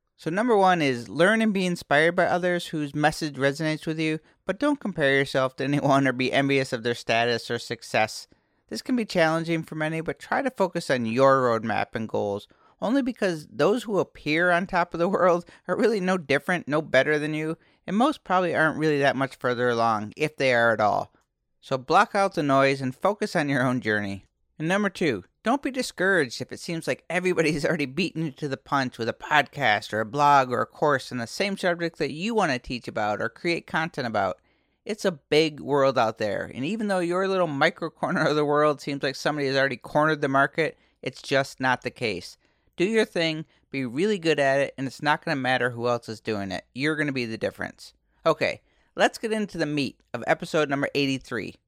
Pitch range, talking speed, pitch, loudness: 135-175 Hz, 220 wpm, 150 Hz, -25 LUFS